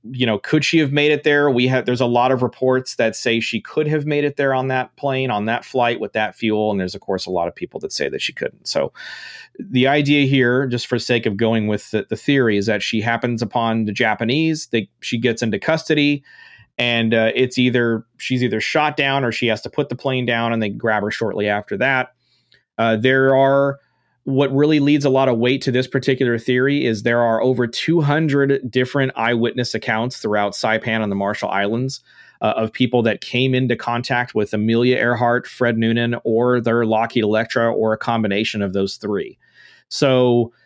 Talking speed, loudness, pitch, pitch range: 210 wpm, -18 LUFS, 120 Hz, 115-135 Hz